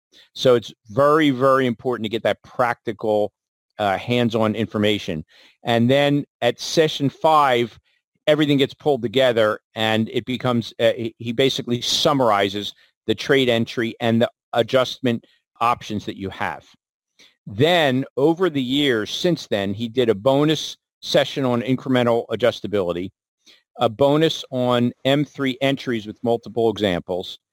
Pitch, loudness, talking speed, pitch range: 120 Hz, -20 LUFS, 130 wpm, 110-135 Hz